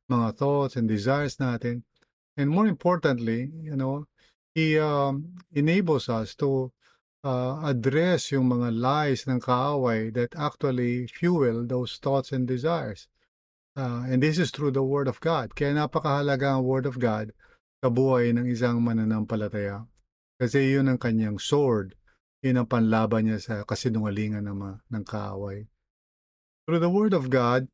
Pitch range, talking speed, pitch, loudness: 115-145 Hz, 145 wpm, 130 Hz, -26 LUFS